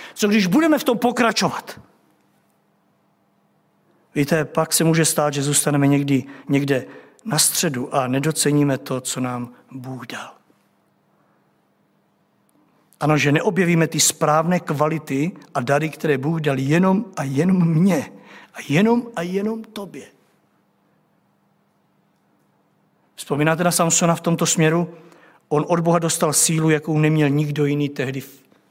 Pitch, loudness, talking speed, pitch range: 155 Hz, -19 LUFS, 130 wpm, 140-170 Hz